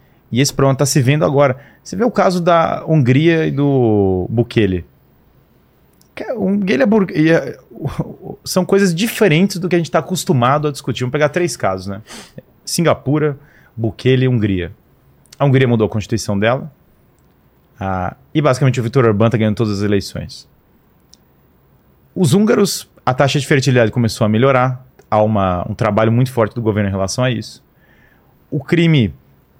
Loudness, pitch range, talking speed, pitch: -15 LUFS, 110-155 Hz, 165 wpm, 130 Hz